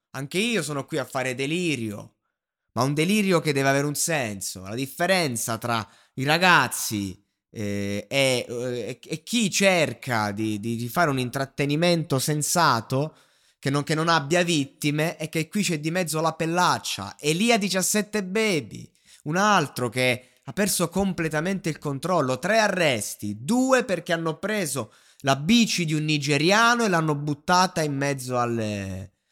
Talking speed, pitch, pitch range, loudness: 150 wpm, 150 Hz, 125-175 Hz, -24 LUFS